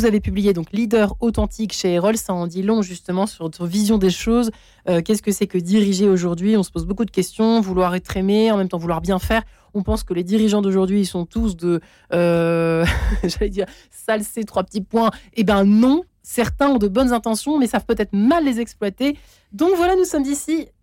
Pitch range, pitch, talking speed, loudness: 185-225 Hz, 210 Hz, 220 wpm, -19 LUFS